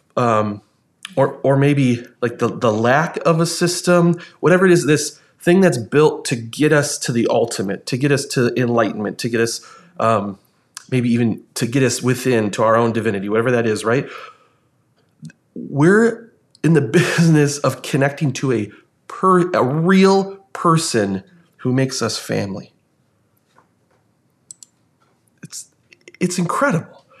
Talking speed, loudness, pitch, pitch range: 145 wpm, -17 LUFS, 140 Hz, 120-170 Hz